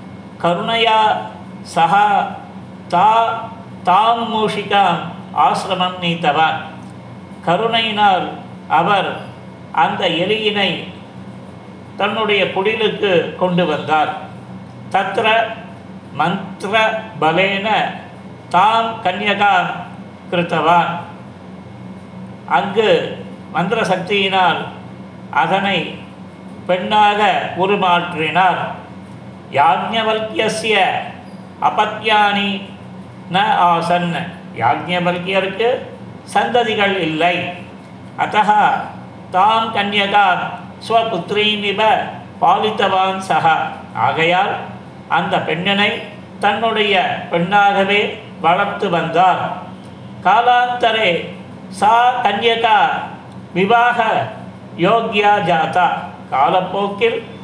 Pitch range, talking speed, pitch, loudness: 175-220 Hz, 55 wpm, 200 Hz, -16 LUFS